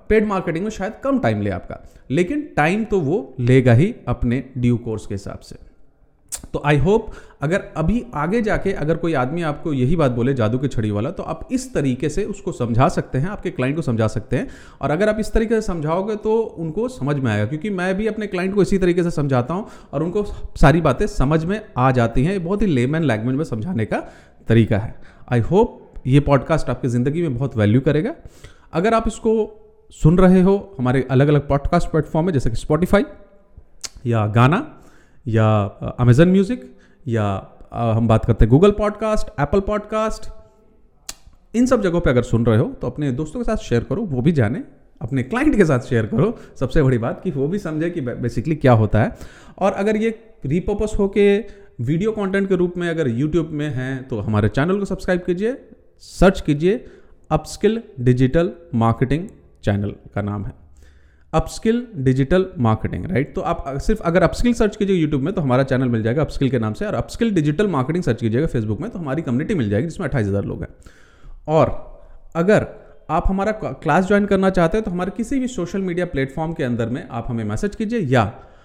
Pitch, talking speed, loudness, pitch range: 155 Hz, 200 wpm, -20 LUFS, 125-200 Hz